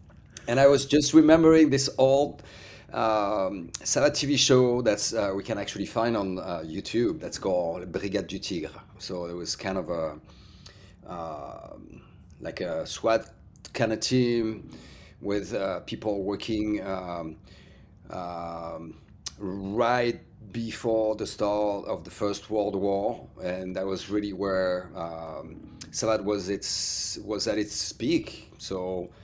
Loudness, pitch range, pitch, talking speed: -27 LUFS, 90-110 Hz, 100 Hz, 135 wpm